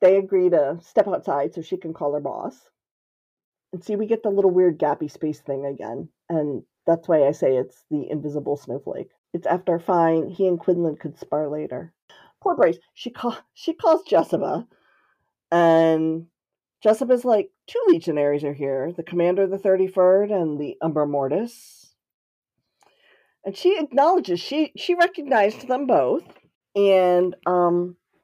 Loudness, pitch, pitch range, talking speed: -22 LUFS, 180 Hz, 155-205 Hz, 155 wpm